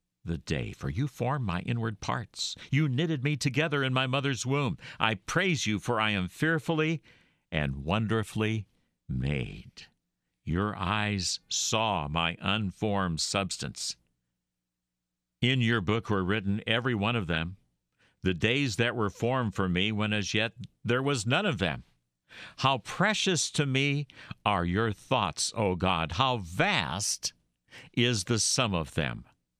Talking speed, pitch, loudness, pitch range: 145 wpm, 110 Hz, -29 LUFS, 90-130 Hz